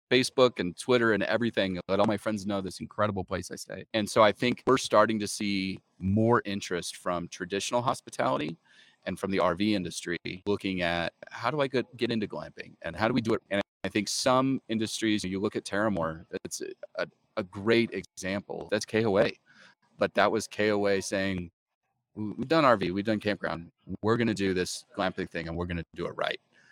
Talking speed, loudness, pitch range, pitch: 200 wpm, -29 LUFS, 95-115 Hz, 105 Hz